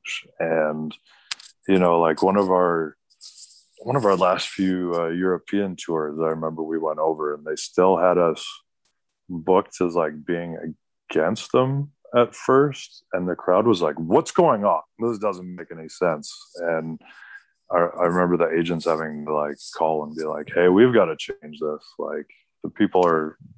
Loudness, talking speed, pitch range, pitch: -22 LUFS, 175 wpm, 80-95 Hz, 85 Hz